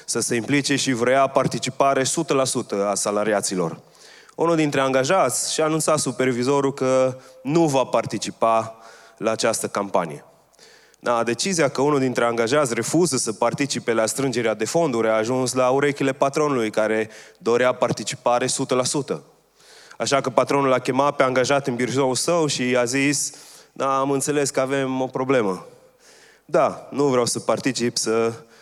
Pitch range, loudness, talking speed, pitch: 120-140 Hz, -21 LUFS, 145 wpm, 130 Hz